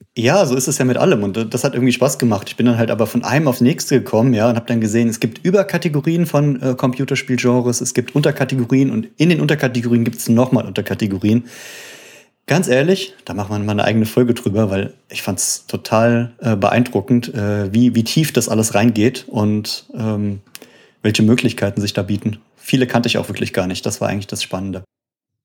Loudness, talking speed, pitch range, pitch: -17 LUFS, 205 wpm, 105-130 Hz, 120 Hz